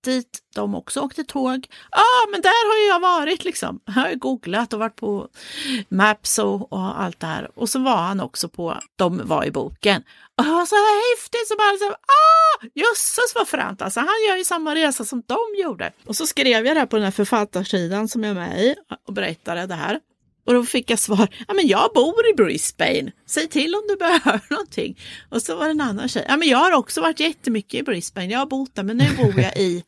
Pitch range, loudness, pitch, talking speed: 215-350 Hz, -20 LUFS, 260 Hz, 230 wpm